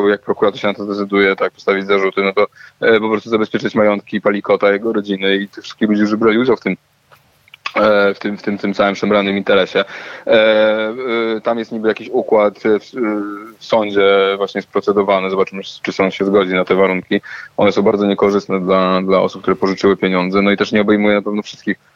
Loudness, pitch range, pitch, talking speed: -15 LUFS, 100-105 Hz, 100 Hz, 200 wpm